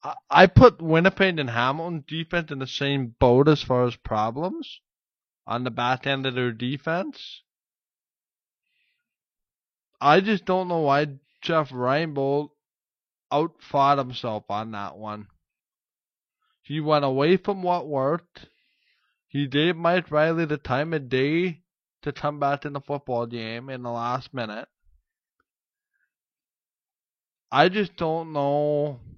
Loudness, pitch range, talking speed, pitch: -23 LUFS, 125-170 Hz, 130 wpm, 145 Hz